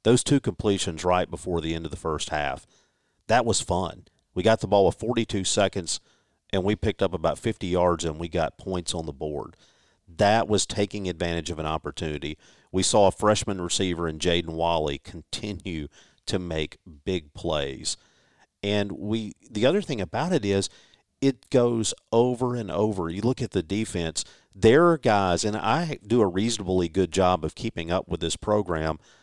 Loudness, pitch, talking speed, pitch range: -25 LUFS, 95 Hz, 185 wpm, 85-110 Hz